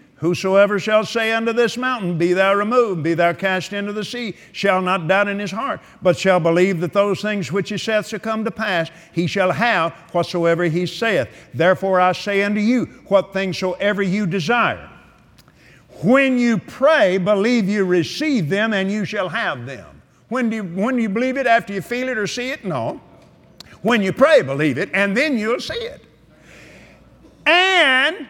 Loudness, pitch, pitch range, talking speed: -18 LUFS, 205 Hz, 185-230 Hz, 190 wpm